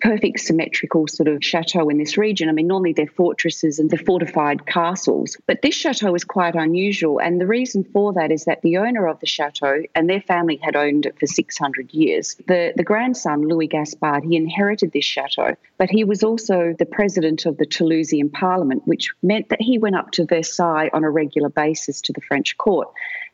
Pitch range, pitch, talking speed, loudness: 155-200 Hz, 170 Hz, 205 wpm, -19 LUFS